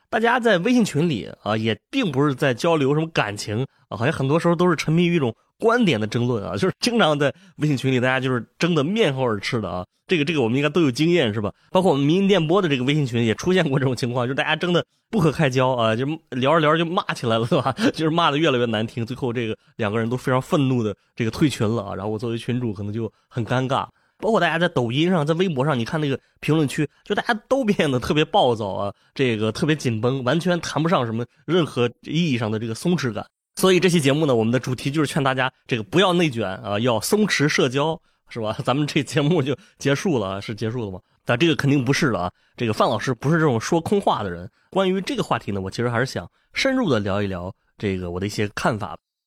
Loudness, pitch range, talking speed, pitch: -21 LUFS, 115-170 Hz, 375 characters per minute, 135 Hz